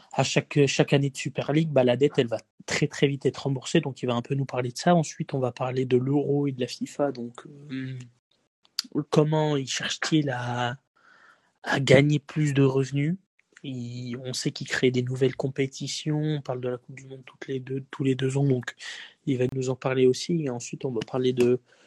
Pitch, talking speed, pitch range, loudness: 135 Hz, 225 wpm, 125-145 Hz, -26 LUFS